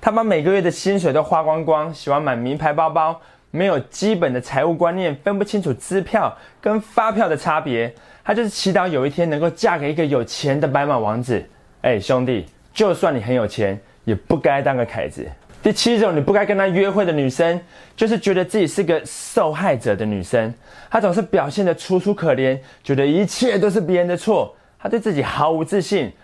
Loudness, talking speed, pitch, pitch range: -19 LUFS, 300 characters per minute, 165 Hz, 135-200 Hz